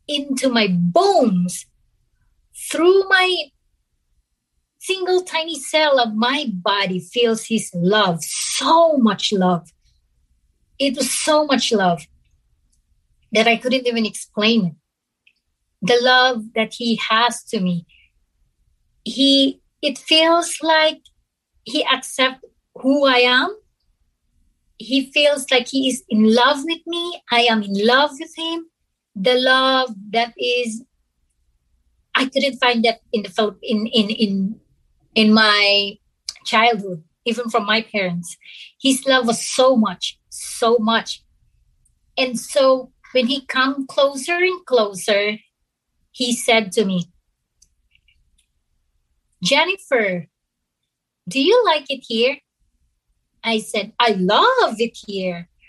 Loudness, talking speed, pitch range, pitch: -18 LUFS, 120 wpm, 195-270 Hz, 235 Hz